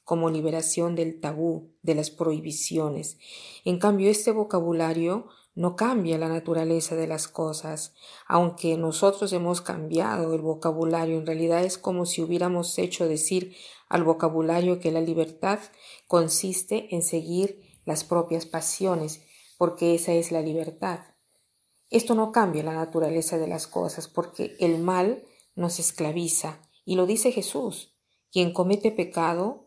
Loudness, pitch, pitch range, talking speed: -26 LUFS, 170 Hz, 160-180 Hz, 140 wpm